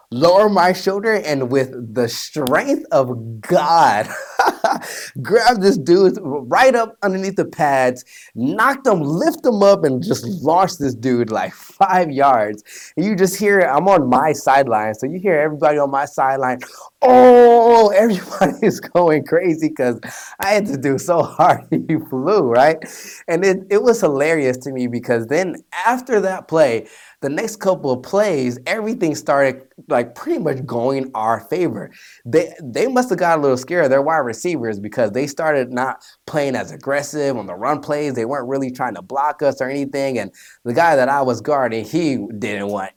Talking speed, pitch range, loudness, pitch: 175 wpm, 130-195 Hz, -17 LUFS, 150 Hz